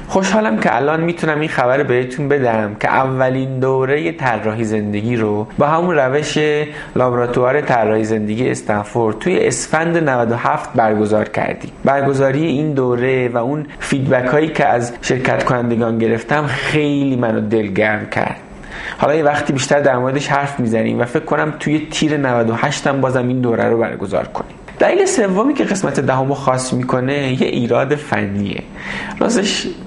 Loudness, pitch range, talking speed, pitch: -16 LUFS, 115-150 Hz, 150 wpm, 130 Hz